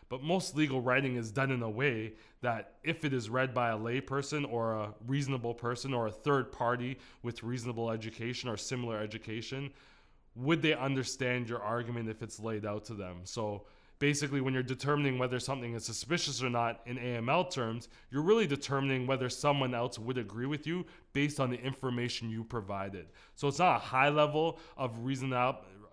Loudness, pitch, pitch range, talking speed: -34 LUFS, 125 Hz, 115-140 Hz, 185 wpm